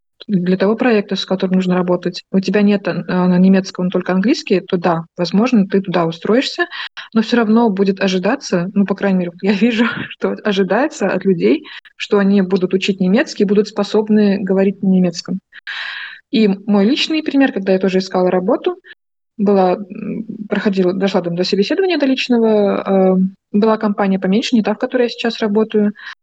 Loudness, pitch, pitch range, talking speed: -16 LUFS, 200 Hz, 190-220 Hz, 165 wpm